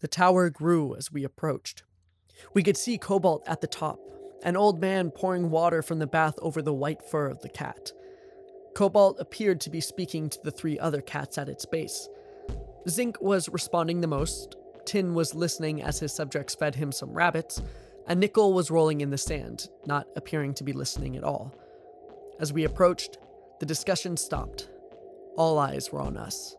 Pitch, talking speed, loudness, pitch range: 170 Hz, 185 wpm, -28 LUFS, 150-200 Hz